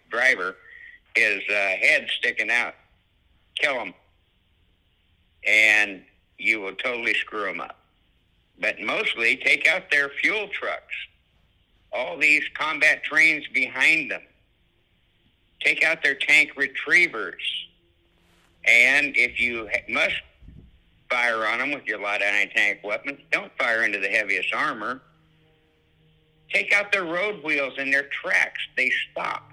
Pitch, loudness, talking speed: 115 Hz, -21 LUFS, 130 wpm